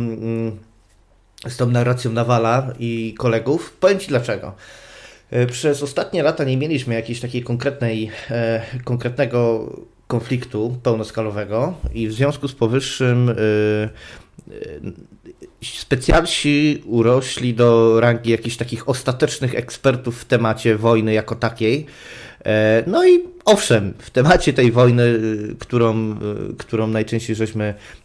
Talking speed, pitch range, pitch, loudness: 105 wpm, 110-125 Hz, 120 Hz, -19 LUFS